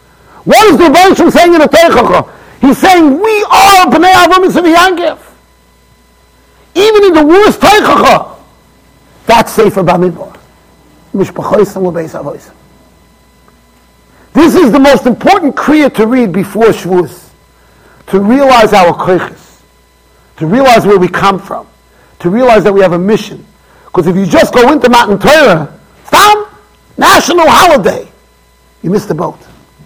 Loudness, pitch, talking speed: -6 LUFS, 250 Hz, 130 wpm